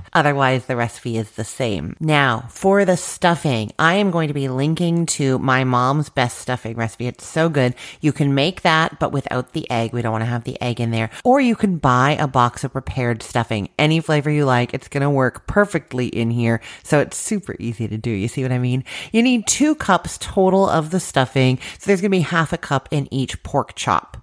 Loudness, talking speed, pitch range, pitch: -19 LUFS, 230 wpm, 120-165 Hz, 135 Hz